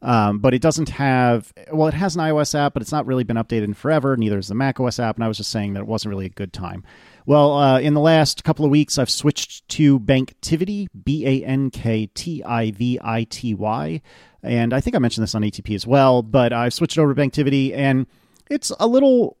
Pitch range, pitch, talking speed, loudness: 115-150 Hz, 130 Hz, 240 wpm, -19 LUFS